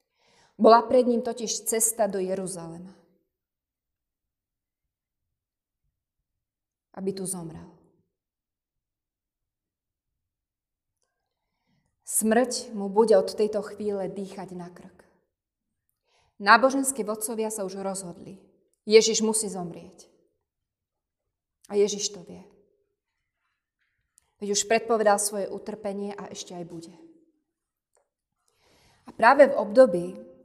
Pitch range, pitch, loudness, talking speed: 185-225 Hz, 200 Hz, -24 LUFS, 90 wpm